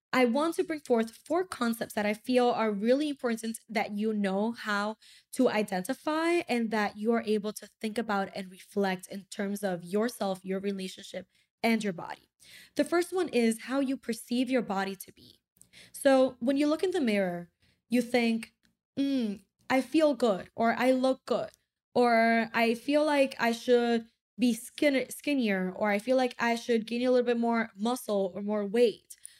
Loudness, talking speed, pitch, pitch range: -29 LUFS, 180 wpm, 230 Hz, 210-255 Hz